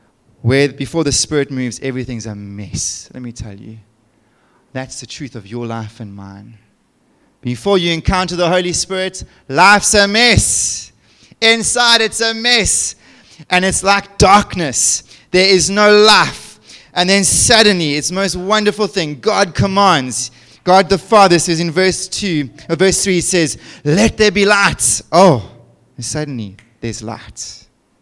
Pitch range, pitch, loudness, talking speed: 120-195 Hz, 160 Hz, -12 LUFS, 155 wpm